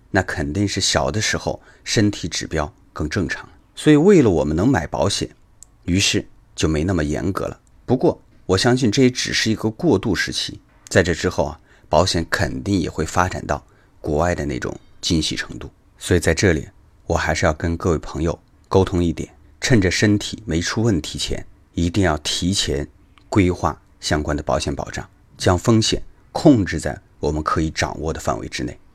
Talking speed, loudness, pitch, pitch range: 270 characters per minute, -20 LUFS, 90 Hz, 80-100 Hz